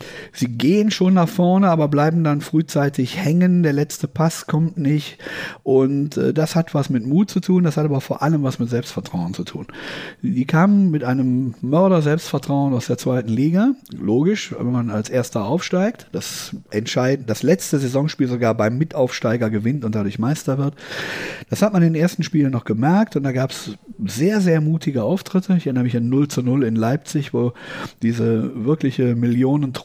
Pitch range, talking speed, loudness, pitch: 125-165 Hz, 180 wpm, -19 LUFS, 145 Hz